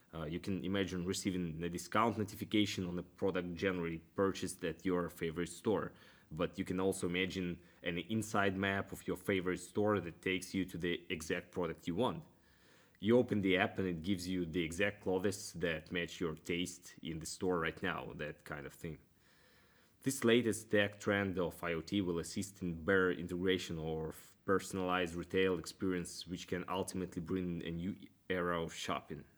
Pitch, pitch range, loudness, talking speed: 90 Hz, 85-100 Hz, -38 LUFS, 175 wpm